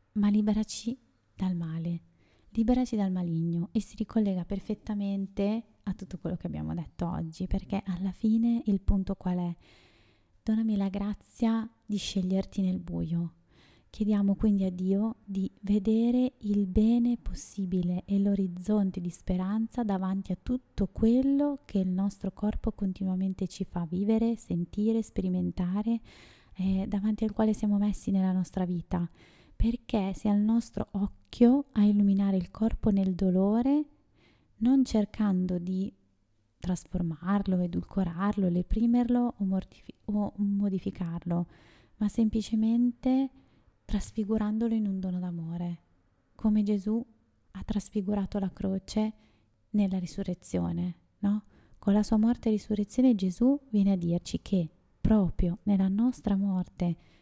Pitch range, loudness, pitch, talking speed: 185-220 Hz, -30 LUFS, 200 Hz, 125 wpm